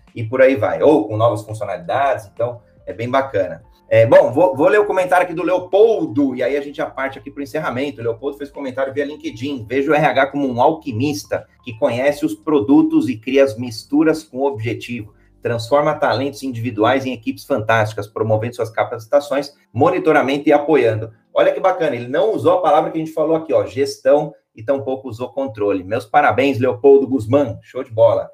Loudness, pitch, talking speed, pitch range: -17 LUFS, 140 Hz, 195 wpm, 120-150 Hz